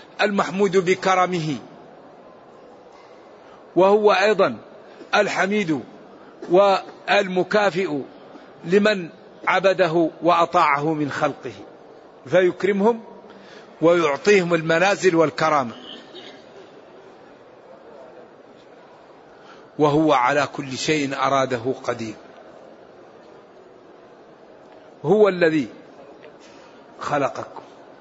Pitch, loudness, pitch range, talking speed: 175 Hz, -20 LUFS, 150-195 Hz, 50 wpm